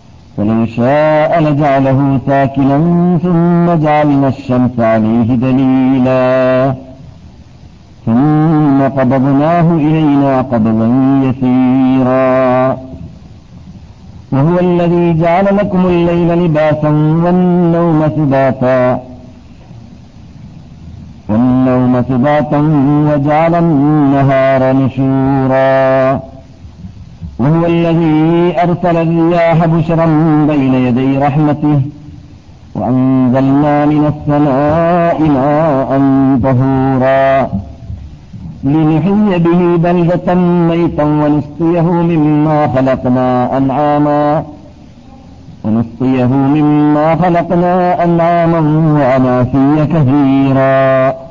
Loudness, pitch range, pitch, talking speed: -10 LUFS, 130-160 Hz, 140 Hz, 65 wpm